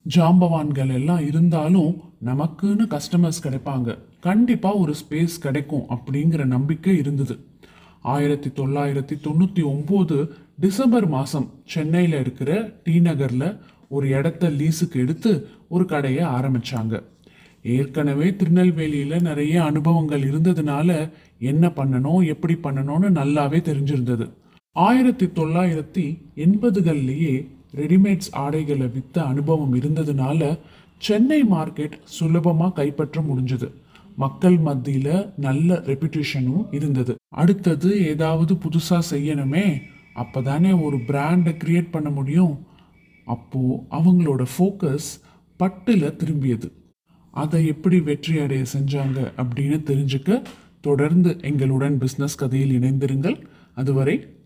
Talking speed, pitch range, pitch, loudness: 95 wpm, 140-175 Hz, 150 Hz, -21 LUFS